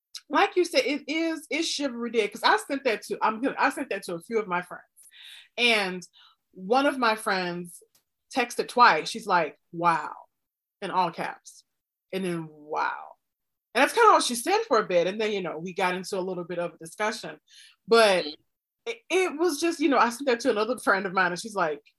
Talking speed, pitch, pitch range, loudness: 220 wpm, 220 Hz, 180-285 Hz, -25 LUFS